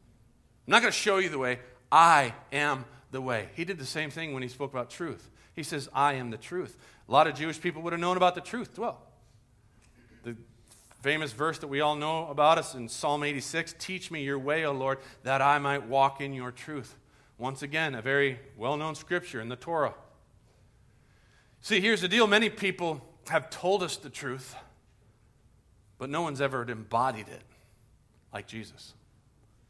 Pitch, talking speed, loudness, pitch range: 135 Hz, 190 wpm, -29 LUFS, 120-160 Hz